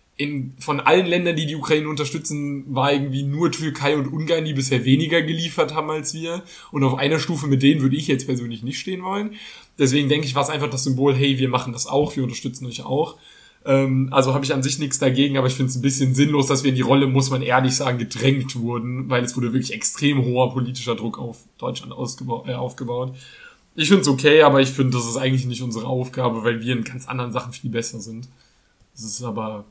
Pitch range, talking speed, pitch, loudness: 125-145 Hz, 230 wpm, 135 Hz, -20 LUFS